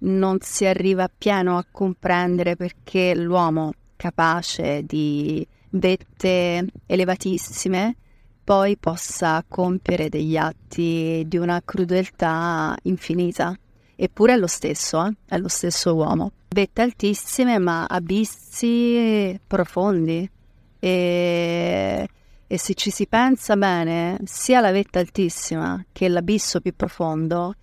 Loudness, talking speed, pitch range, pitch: -21 LUFS, 110 wpm, 170-195 Hz, 180 Hz